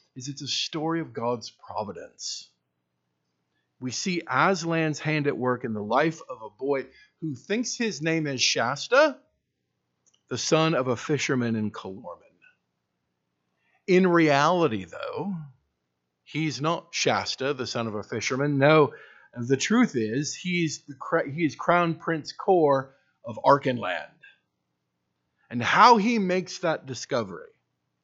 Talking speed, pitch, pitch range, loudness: 130 wpm, 140 Hz, 110-165 Hz, -25 LUFS